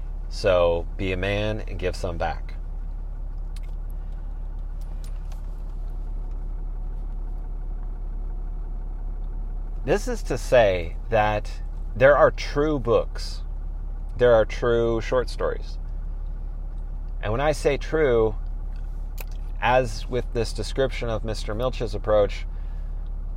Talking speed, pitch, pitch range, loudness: 90 wpm, 80 Hz, 75-105 Hz, -25 LUFS